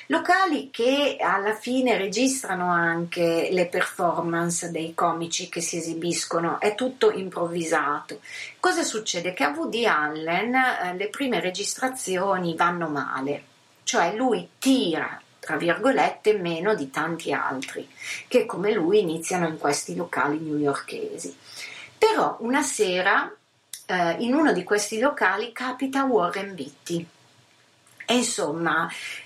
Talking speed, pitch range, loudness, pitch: 120 wpm, 170-250 Hz, -24 LUFS, 185 Hz